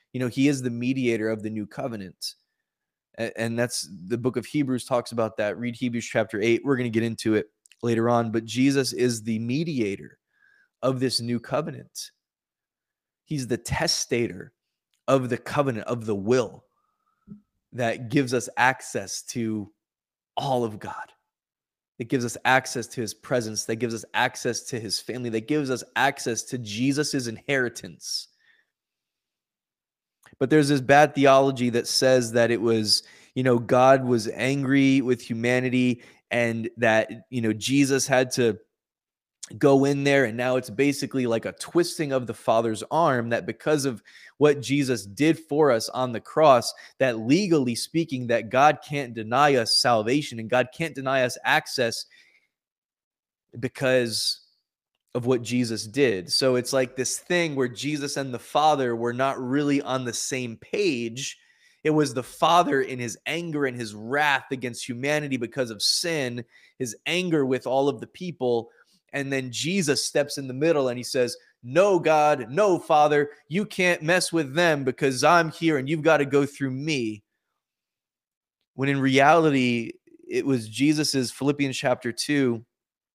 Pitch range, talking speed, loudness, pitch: 120-145 Hz, 160 wpm, -24 LUFS, 130 Hz